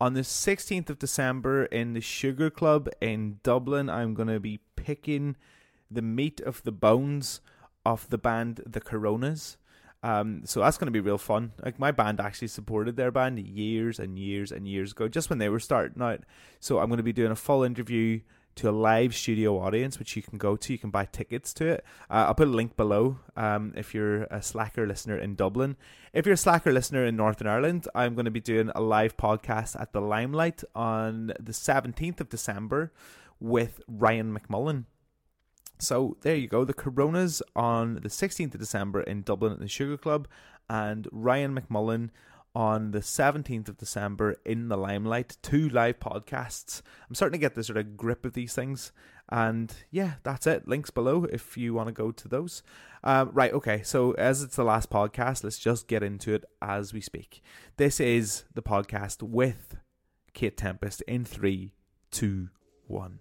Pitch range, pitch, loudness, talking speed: 105-130 Hz, 115 Hz, -29 LUFS, 190 wpm